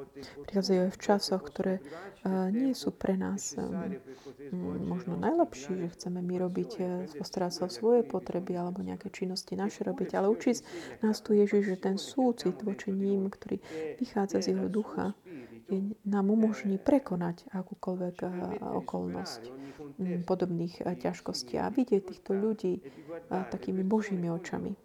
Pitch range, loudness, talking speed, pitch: 175-205 Hz, -32 LUFS, 130 wpm, 190 Hz